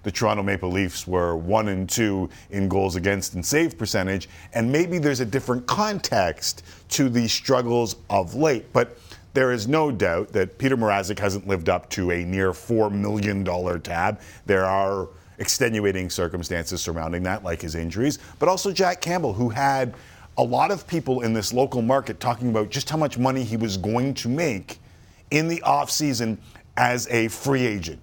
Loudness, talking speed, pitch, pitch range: -23 LUFS, 180 wpm, 110 Hz, 95-130 Hz